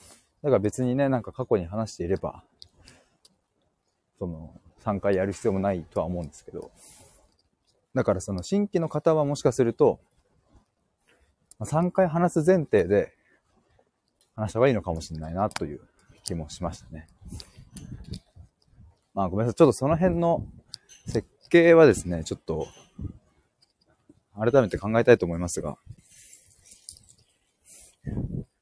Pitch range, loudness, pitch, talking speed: 90-135 Hz, -25 LUFS, 105 Hz, 260 characters per minute